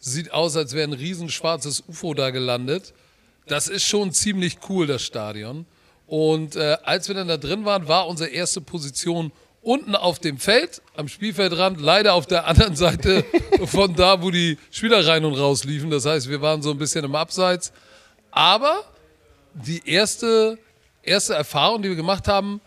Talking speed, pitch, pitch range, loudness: 175 wpm, 170 Hz, 155-195 Hz, -20 LUFS